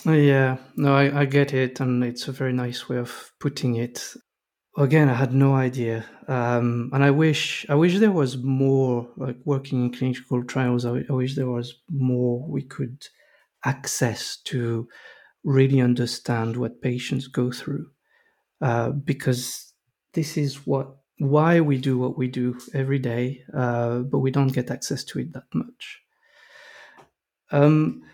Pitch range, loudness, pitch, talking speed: 125-140 Hz, -23 LUFS, 130 Hz, 160 wpm